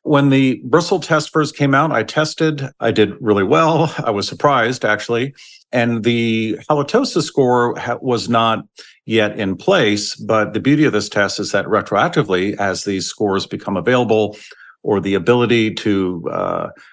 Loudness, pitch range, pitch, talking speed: -17 LUFS, 105-145 Hz, 120 Hz, 160 wpm